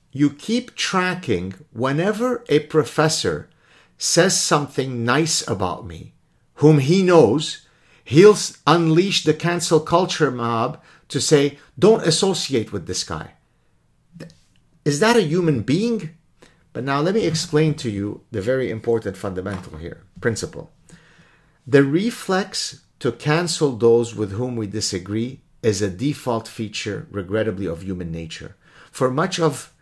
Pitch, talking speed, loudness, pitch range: 150 Hz, 130 wpm, -20 LUFS, 115-165 Hz